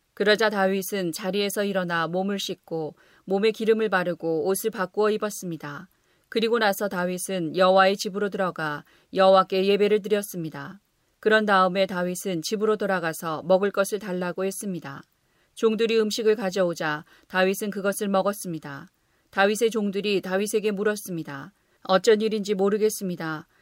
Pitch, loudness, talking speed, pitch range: 190 Hz, -24 LUFS, 350 characters per minute, 180-210 Hz